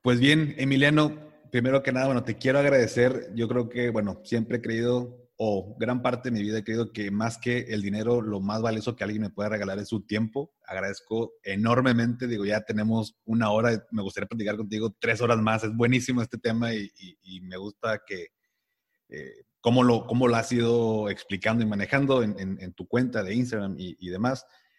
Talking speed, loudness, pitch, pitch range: 210 wpm, -26 LUFS, 115 Hz, 105-125 Hz